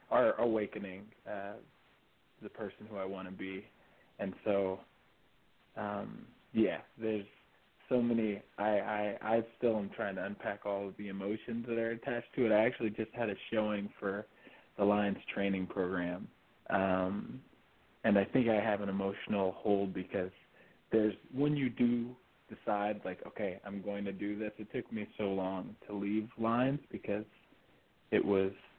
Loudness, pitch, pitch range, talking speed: -35 LUFS, 105 Hz, 100-110 Hz, 165 wpm